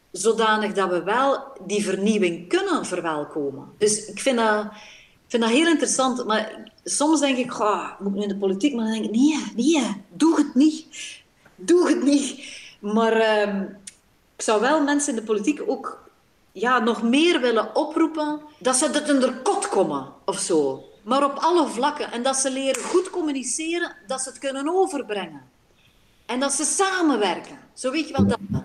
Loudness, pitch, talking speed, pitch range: -22 LUFS, 260 Hz, 180 wpm, 210-300 Hz